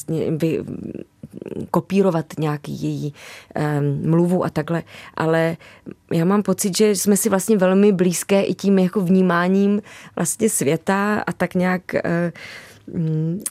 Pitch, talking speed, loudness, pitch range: 180 Hz, 125 wpm, -20 LUFS, 160-195 Hz